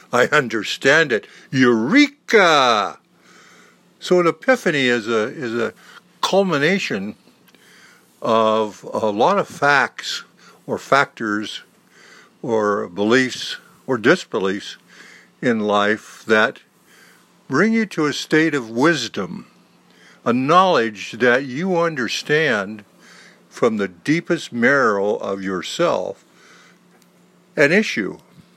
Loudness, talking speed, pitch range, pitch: -18 LUFS, 95 wpm, 110-180 Hz, 125 Hz